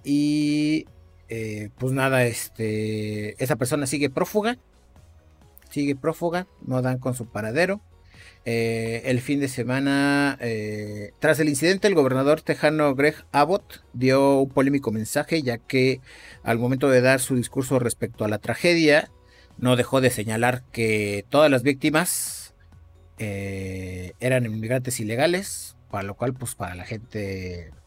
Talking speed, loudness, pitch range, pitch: 140 wpm, -23 LUFS, 105-140 Hz, 125 Hz